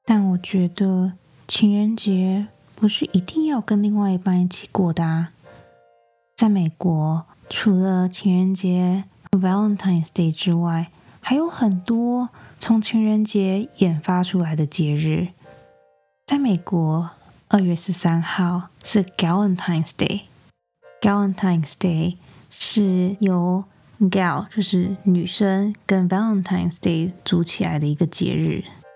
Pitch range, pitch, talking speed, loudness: 170-205 Hz, 185 Hz, 265 characters per minute, -21 LUFS